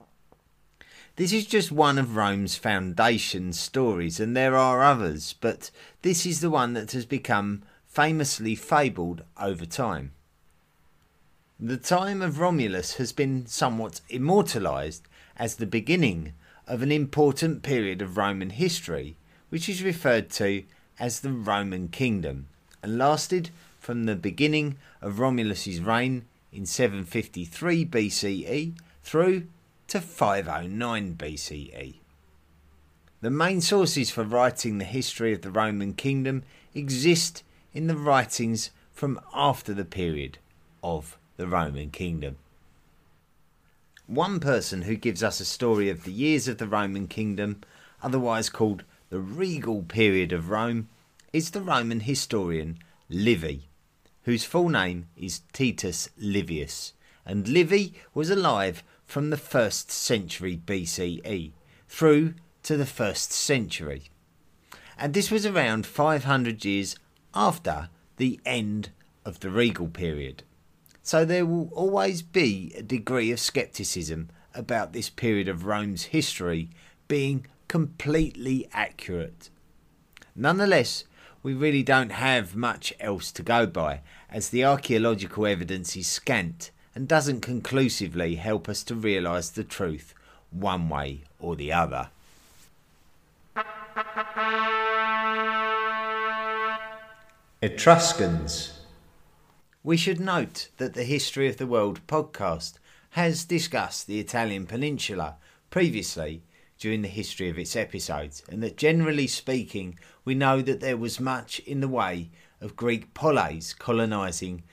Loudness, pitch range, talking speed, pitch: -26 LUFS, 90-145 Hz, 125 wpm, 115 Hz